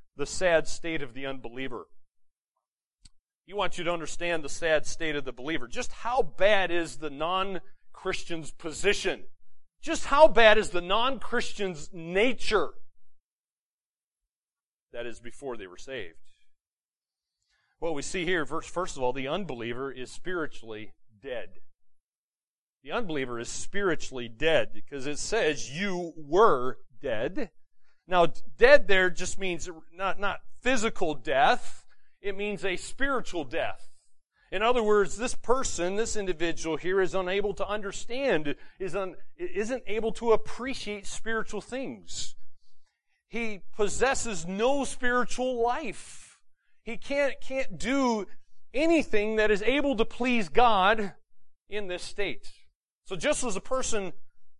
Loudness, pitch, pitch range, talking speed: -28 LUFS, 195 Hz, 160-235 Hz, 130 wpm